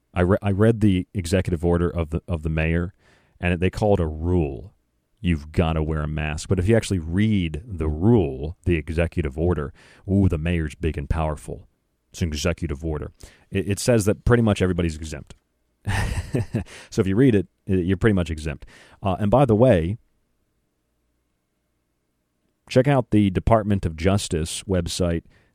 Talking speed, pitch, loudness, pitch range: 170 wpm, 90 Hz, -22 LUFS, 80-100 Hz